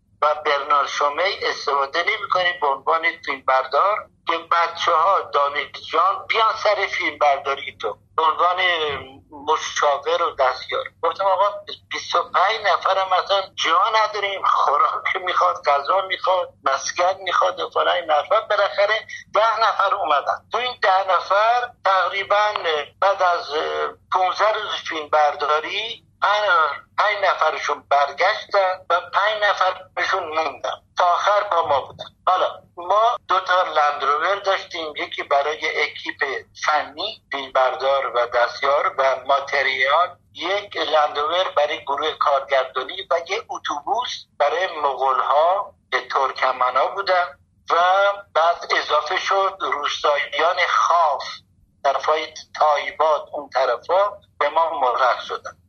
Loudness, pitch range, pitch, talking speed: -20 LUFS, 145-195 Hz, 170 Hz, 120 wpm